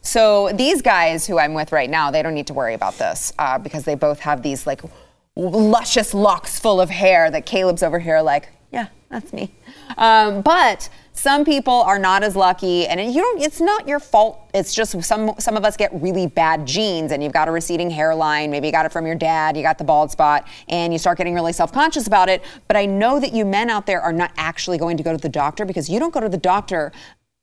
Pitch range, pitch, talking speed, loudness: 160-215 Hz, 180 Hz, 240 wpm, -18 LUFS